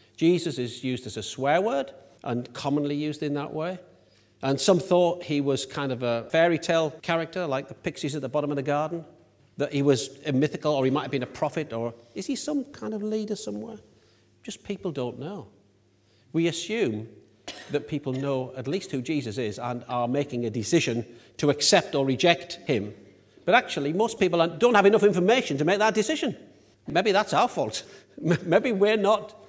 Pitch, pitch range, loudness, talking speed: 145 Hz, 125-175 Hz, -26 LUFS, 195 wpm